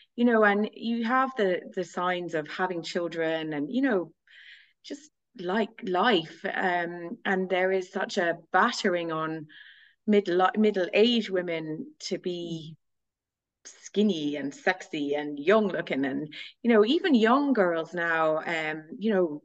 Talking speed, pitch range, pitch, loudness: 145 wpm, 160-210 Hz, 180 Hz, -27 LUFS